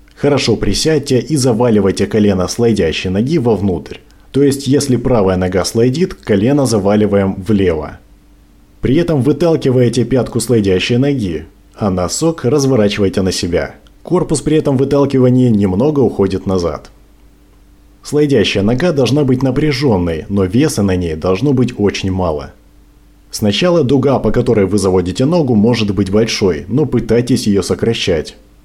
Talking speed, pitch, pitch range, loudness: 130 wpm, 115 Hz, 100-140 Hz, -13 LUFS